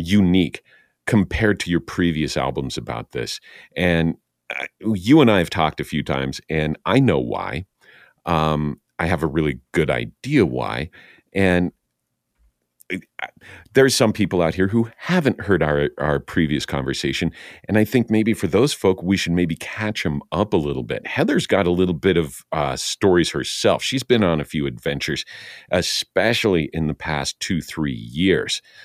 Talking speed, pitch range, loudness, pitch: 165 wpm, 75-100 Hz, -20 LUFS, 85 Hz